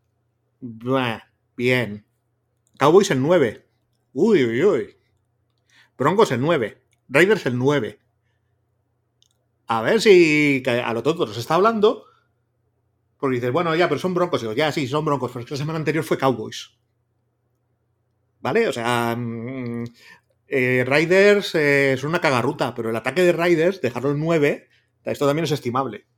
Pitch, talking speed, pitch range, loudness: 125 Hz, 145 wpm, 115-150 Hz, -20 LUFS